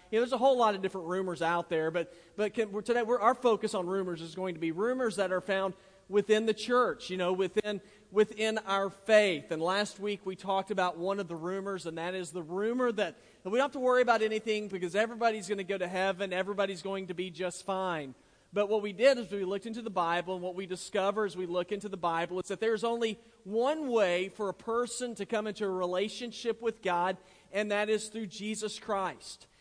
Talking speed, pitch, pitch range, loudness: 235 wpm, 200 Hz, 185-220 Hz, -32 LUFS